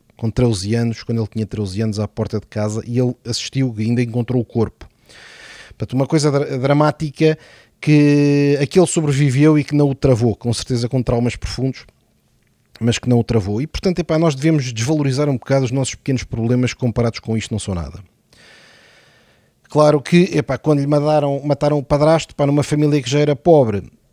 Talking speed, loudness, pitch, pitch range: 185 wpm, -17 LUFS, 130 Hz, 115-145 Hz